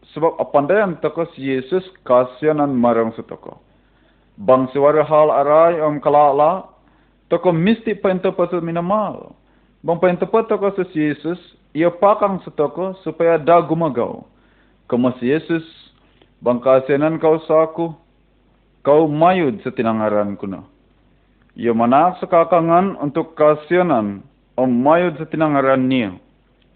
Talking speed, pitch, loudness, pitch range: 125 wpm, 160 Hz, -17 LUFS, 135-175 Hz